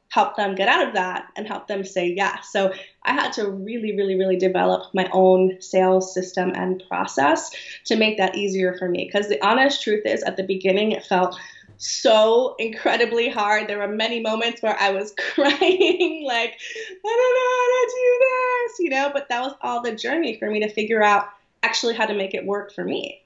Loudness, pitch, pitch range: -21 LUFS, 215 Hz, 190-260 Hz